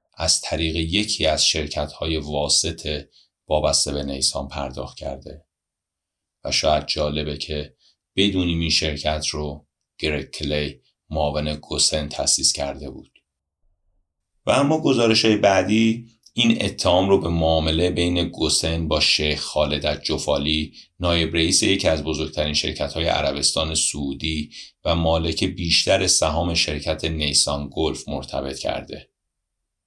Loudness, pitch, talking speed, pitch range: -21 LUFS, 80 Hz, 125 wpm, 75-85 Hz